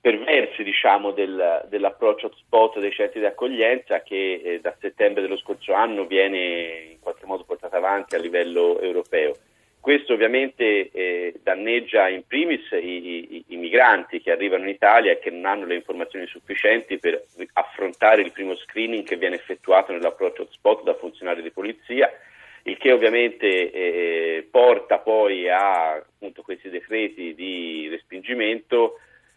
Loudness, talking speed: -21 LUFS, 145 wpm